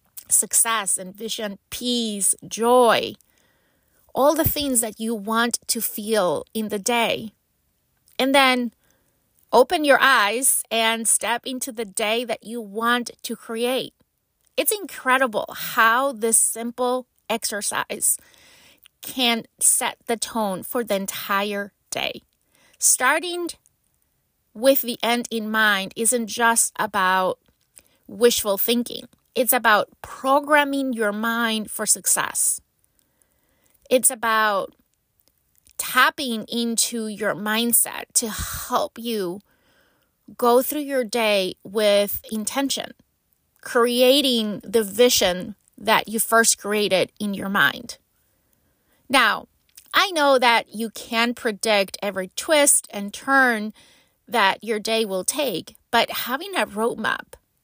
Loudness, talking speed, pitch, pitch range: -21 LUFS, 110 wpm, 230 Hz, 215-255 Hz